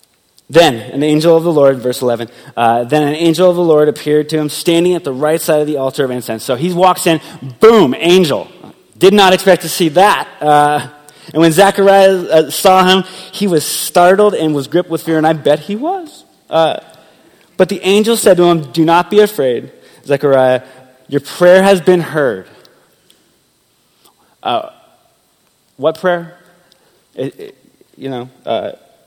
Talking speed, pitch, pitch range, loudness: 175 wpm, 165 Hz, 150-185 Hz, -11 LUFS